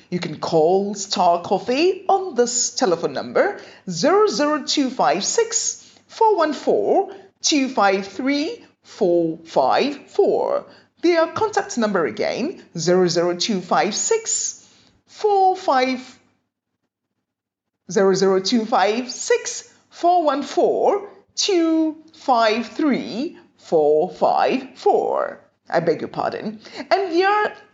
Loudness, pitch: -20 LUFS, 285 Hz